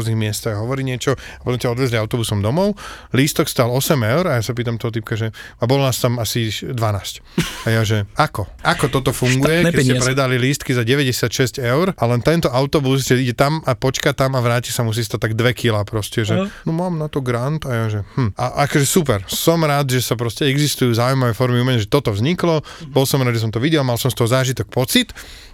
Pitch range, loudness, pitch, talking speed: 115-140 Hz, -18 LUFS, 125 Hz, 230 wpm